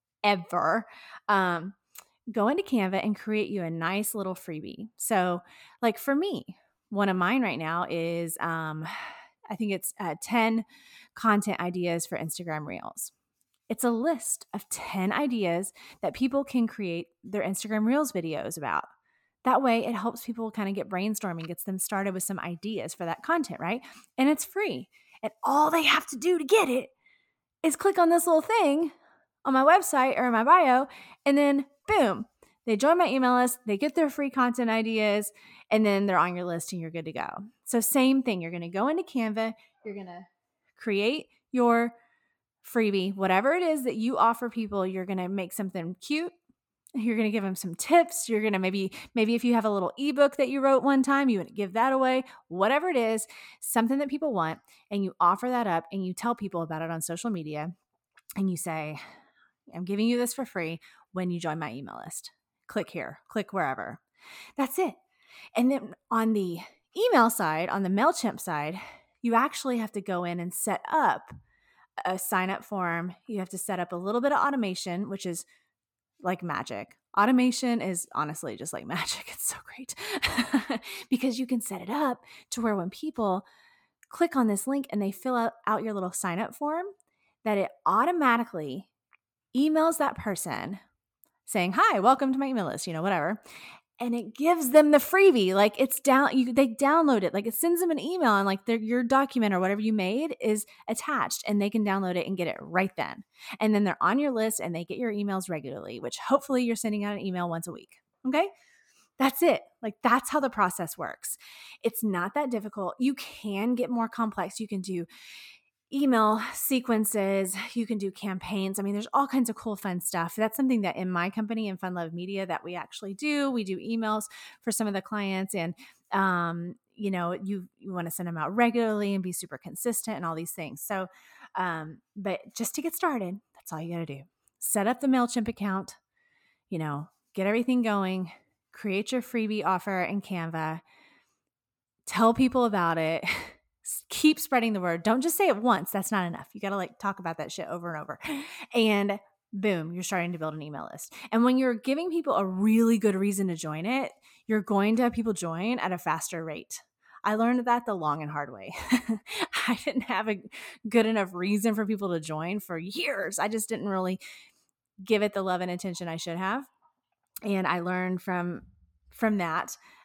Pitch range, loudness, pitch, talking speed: 185-255 Hz, -28 LUFS, 215 Hz, 200 wpm